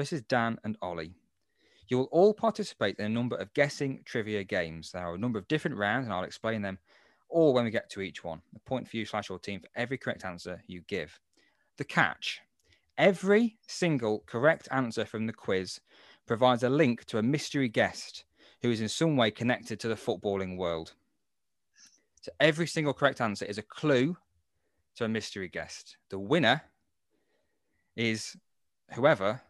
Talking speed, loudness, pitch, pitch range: 180 wpm, -30 LUFS, 115 Hz, 100-140 Hz